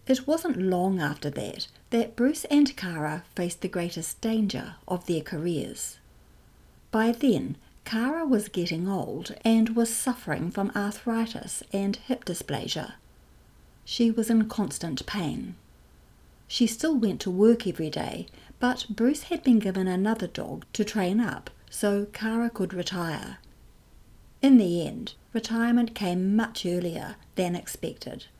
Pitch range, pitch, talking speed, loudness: 180-235 Hz, 210 Hz, 135 wpm, -27 LUFS